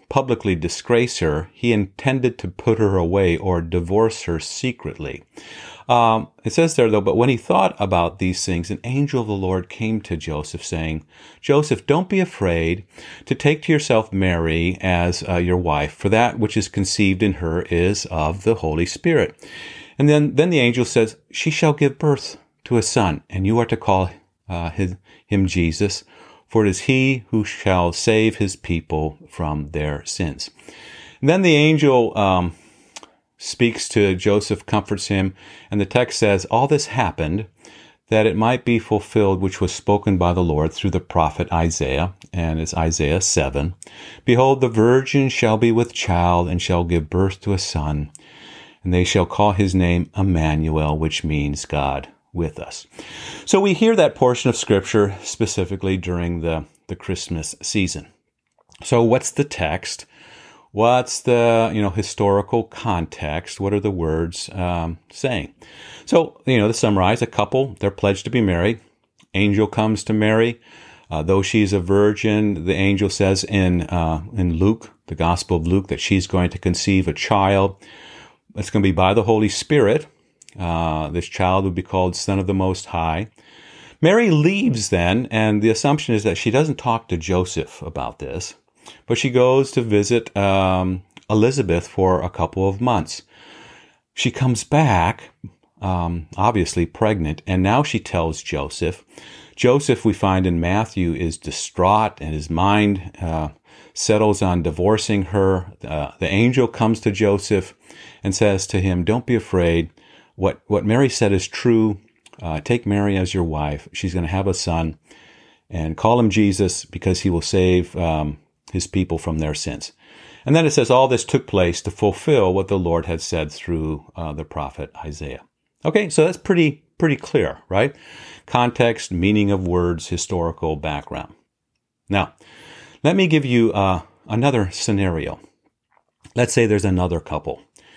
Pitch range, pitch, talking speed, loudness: 85-115 Hz, 100 Hz, 170 wpm, -19 LUFS